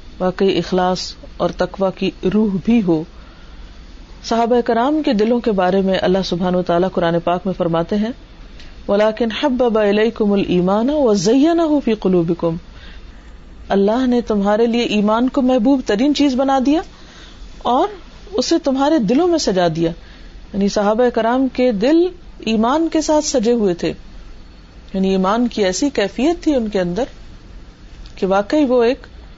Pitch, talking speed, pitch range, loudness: 220 Hz, 135 wpm, 185-260 Hz, -17 LUFS